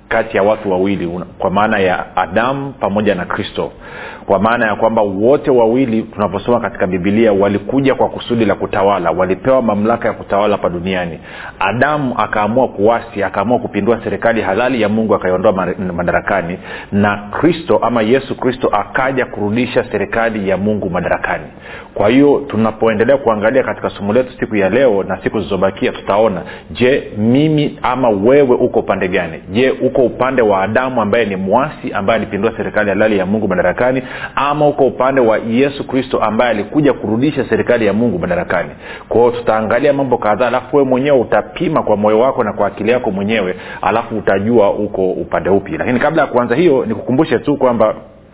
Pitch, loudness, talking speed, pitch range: 110 Hz, -14 LUFS, 160 wpm, 100-125 Hz